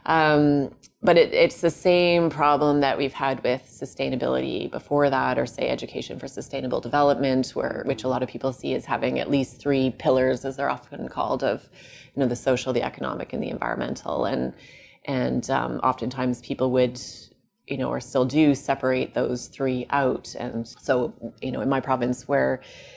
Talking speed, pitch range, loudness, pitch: 185 wpm, 125-140 Hz, -24 LUFS, 130 Hz